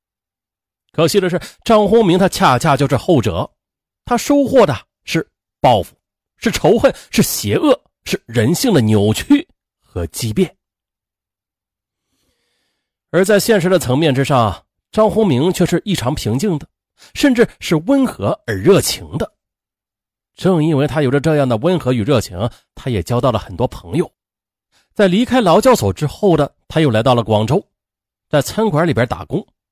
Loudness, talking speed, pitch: -15 LUFS, 220 characters per minute, 140 Hz